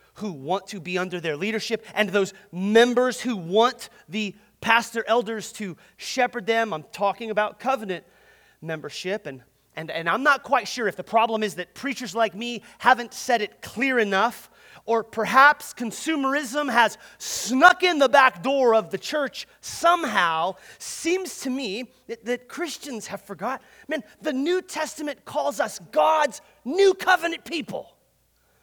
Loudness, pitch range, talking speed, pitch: -23 LUFS, 200-275 Hz, 155 wpm, 230 Hz